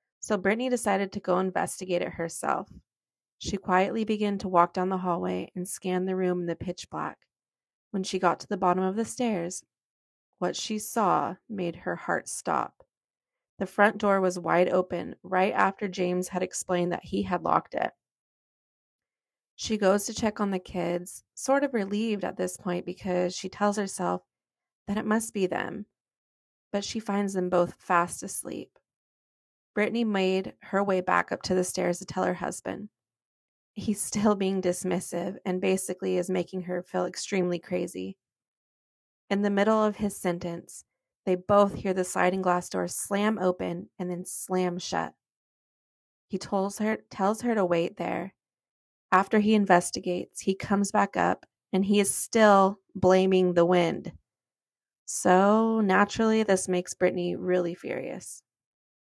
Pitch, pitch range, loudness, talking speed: 185 Hz, 180-205 Hz, -27 LUFS, 160 wpm